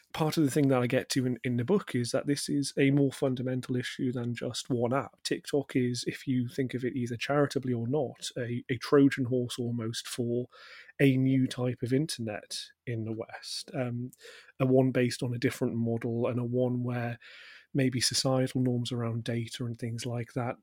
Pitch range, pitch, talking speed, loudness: 120-135 Hz, 125 Hz, 205 wpm, -30 LUFS